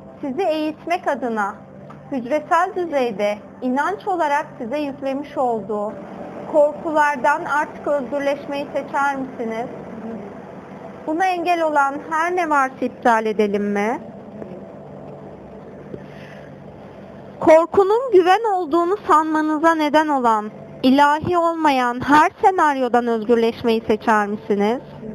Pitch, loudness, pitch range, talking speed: 280 Hz, -19 LUFS, 225-310 Hz, 90 wpm